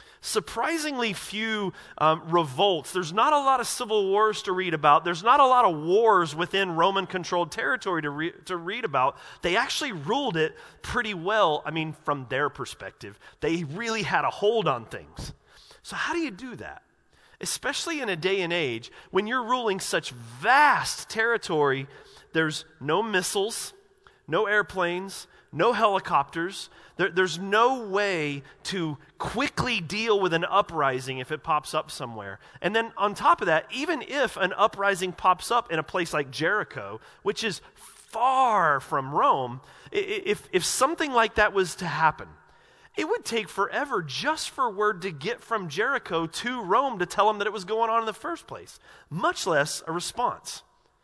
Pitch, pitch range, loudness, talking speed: 195 Hz, 160-230 Hz, -25 LUFS, 170 wpm